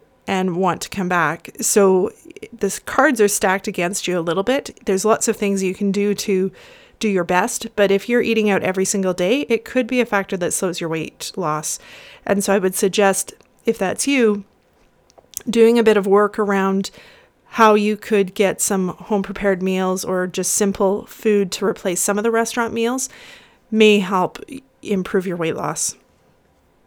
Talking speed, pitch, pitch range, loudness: 185 wpm, 200 Hz, 185-225 Hz, -19 LUFS